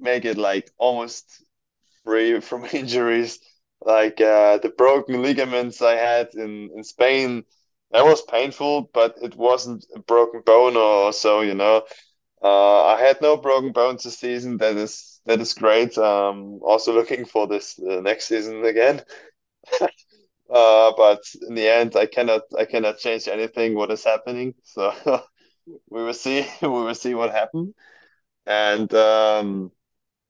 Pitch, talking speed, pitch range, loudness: 115 Hz, 150 wpm, 110-125 Hz, -19 LUFS